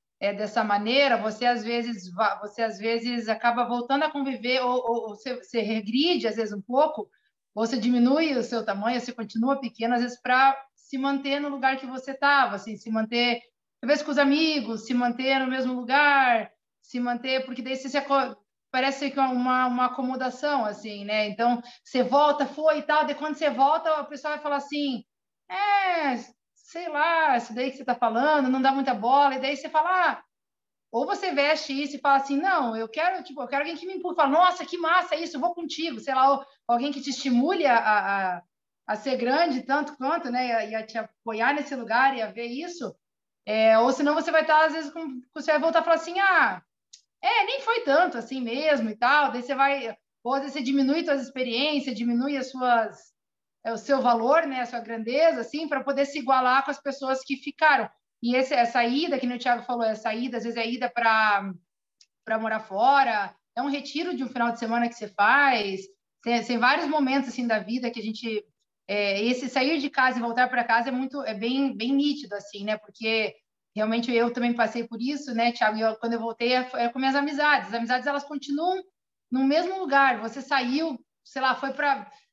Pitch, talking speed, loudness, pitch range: 260 Hz, 215 wpm, -25 LUFS, 235-285 Hz